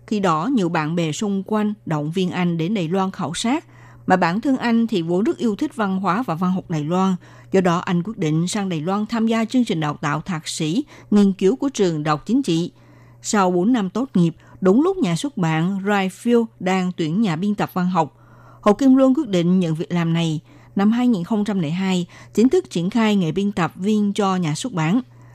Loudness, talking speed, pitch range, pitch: -20 LUFS, 225 wpm, 170-215 Hz, 190 Hz